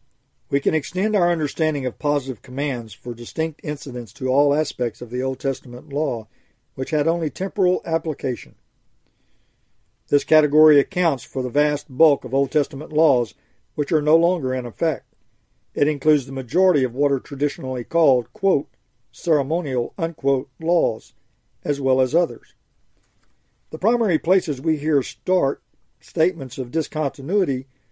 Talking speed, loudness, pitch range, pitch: 145 wpm, -21 LUFS, 130-160 Hz, 145 Hz